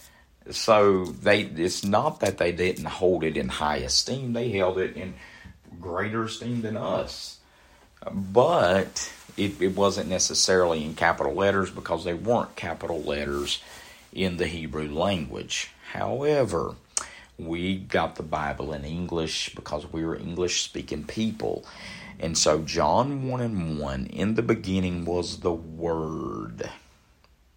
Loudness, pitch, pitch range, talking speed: -26 LUFS, 90 Hz, 80-100 Hz, 130 wpm